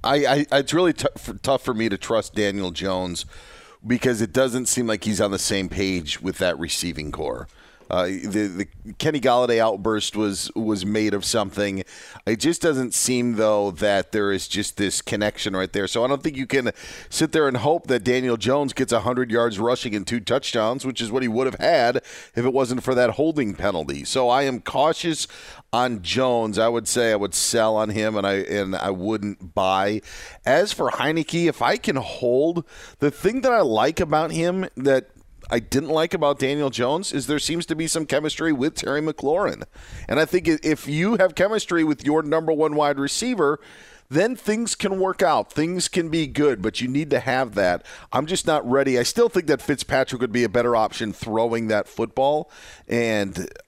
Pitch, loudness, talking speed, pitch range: 125 Hz, -22 LUFS, 205 wpm, 105-150 Hz